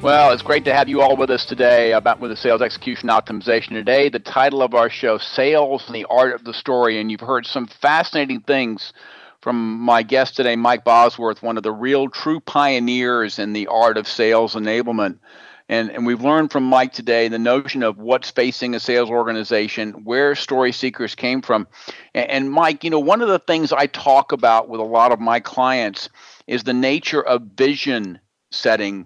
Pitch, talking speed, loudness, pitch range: 125 Hz, 200 wpm, -18 LUFS, 115-135 Hz